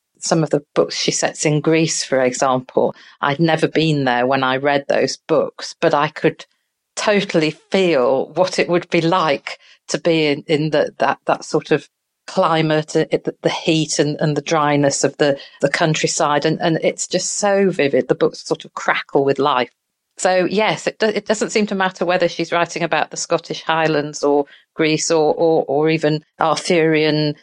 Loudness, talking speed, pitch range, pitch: -18 LUFS, 190 wpm, 150-175 Hz, 160 Hz